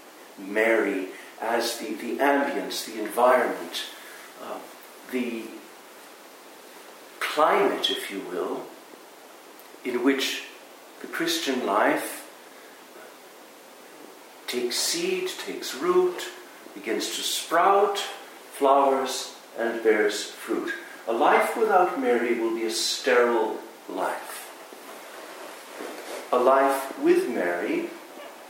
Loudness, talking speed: -25 LUFS, 90 wpm